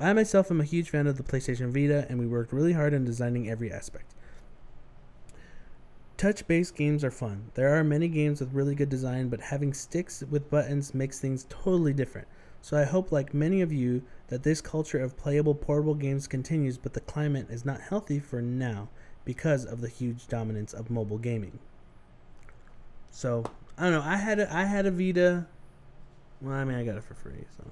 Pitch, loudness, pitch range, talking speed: 135 Hz, -29 LUFS, 120-150 Hz, 195 wpm